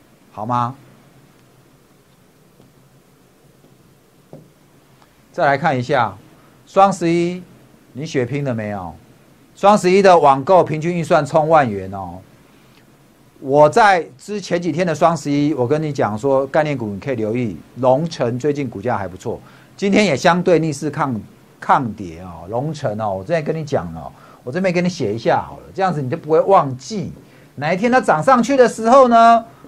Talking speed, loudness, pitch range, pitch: 230 characters per minute, -16 LUFS, 125-175 Hz, 145 Hz